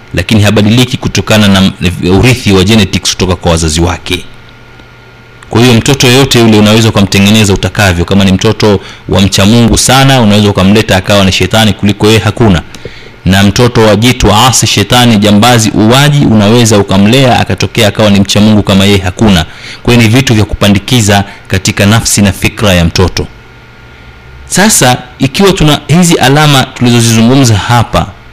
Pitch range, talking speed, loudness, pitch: 100-120 Hz, 140 wpm, -6 LUFS, 105 Hz